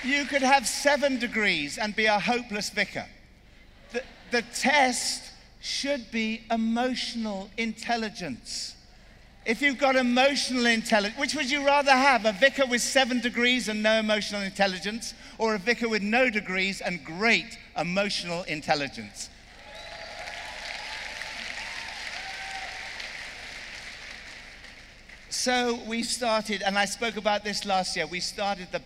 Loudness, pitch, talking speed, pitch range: -26 LUFS, 225 Hz, 125 wpm, 200-250 Hz